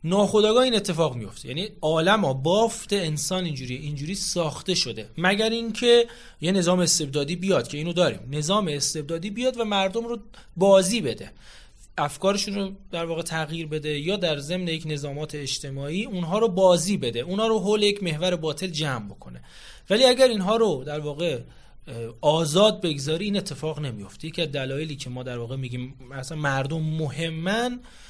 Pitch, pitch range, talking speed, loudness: 170 Hz, 150-200 Hz, 160 wpm, -24 LUFS